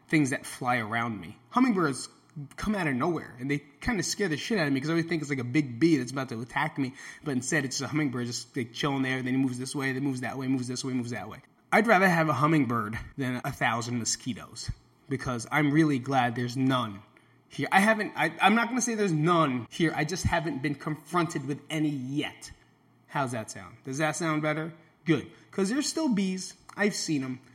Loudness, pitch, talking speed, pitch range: -28 LUFS, 140 Hz, 235 wpm, 125-160 Hz